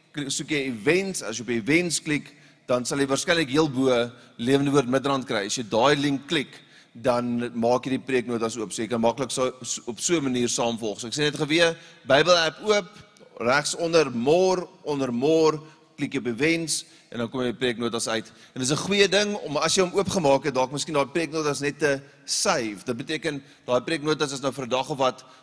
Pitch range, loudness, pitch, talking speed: 125-160 Hz, -24 LUFS, 140 Hz, 215 wpm